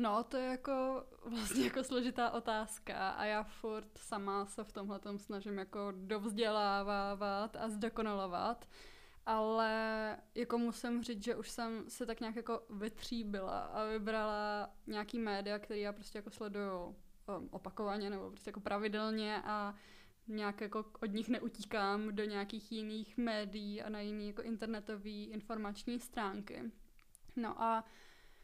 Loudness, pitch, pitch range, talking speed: -41 LUFS, 215 Hz, 205-230 Hz, 135 wpm